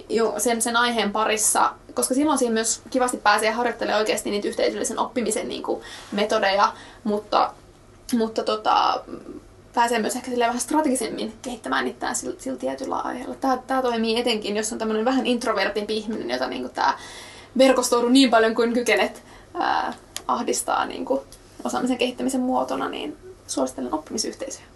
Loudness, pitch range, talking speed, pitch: -23 LUFS, 220-255 Hz, 155 wpm, 235 Hz